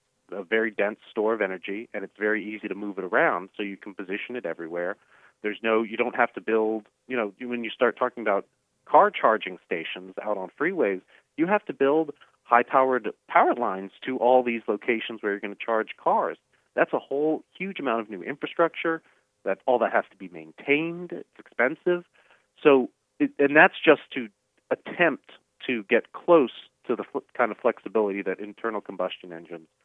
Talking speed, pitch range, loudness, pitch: 190 wpm, 105-140 Hz, -25 LUFS, 115 Hz